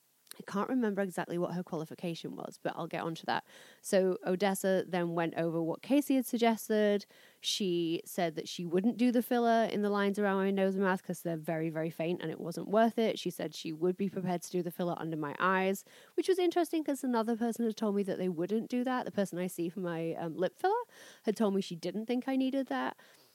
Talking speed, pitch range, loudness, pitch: 240 wpm, 170-225 Hz, -33 LUFS, 190 Hz